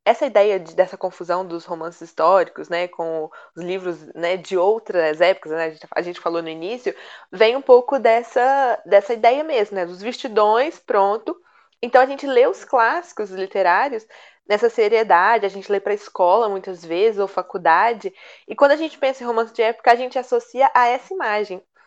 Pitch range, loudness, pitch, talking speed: 180-255 Hz, -19 LUFS, 210 Hz, 185 wpm